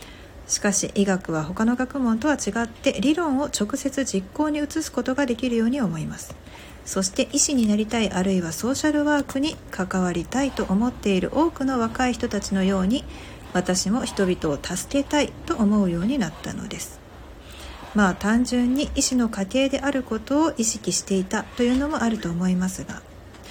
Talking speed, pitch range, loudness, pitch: 355 characters per minute, 185-270 Hz, -23 LUFS, 220 Hz